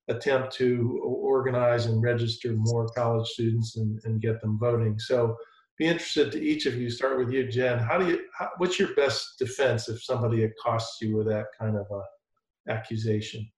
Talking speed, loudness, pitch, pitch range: 180 wpm, -27 LUFS, 120 Hz, 110-130 Hz